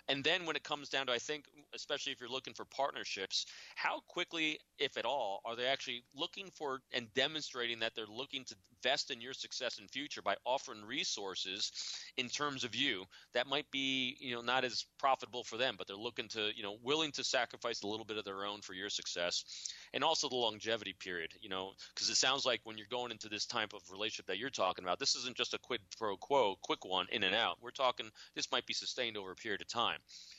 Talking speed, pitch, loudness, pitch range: 235 wpm, 125 Hz, -38 LUFS, 110-135 Hz